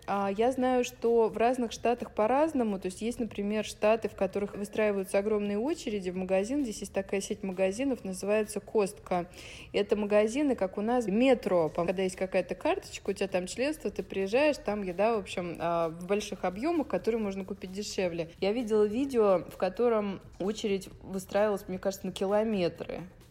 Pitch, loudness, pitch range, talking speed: 205 Hz, -30 LUFS, 190-230 Hz, 165 wpm